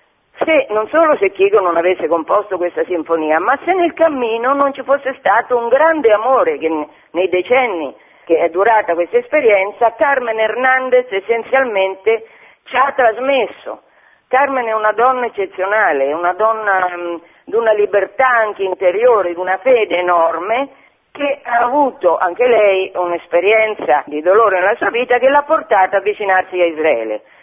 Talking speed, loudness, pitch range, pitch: 155 wpm, -14 LUFS, 180-260 Hz, 215 Hz